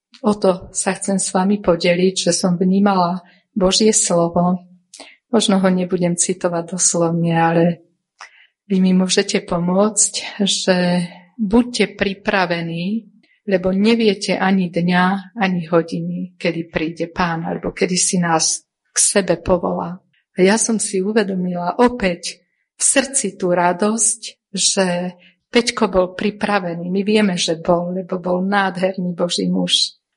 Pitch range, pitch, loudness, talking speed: 175-200 Hz, 185 Hz, -17 LUFS, 125 wpm